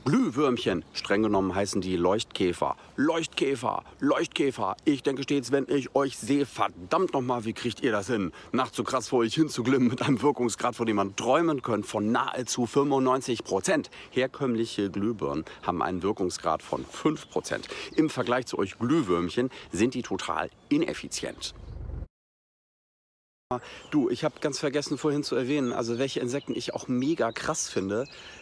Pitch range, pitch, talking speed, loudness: 115-140 Hz, 125 Hz, 155 wpm, -28 LUFS